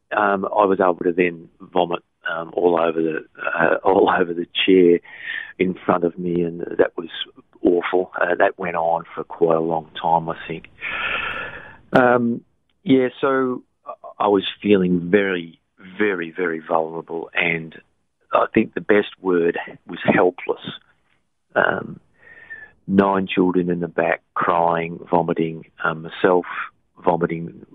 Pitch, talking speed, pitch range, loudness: 90 Hz, 140 wpm, 85-100 Hz, -20 LUFS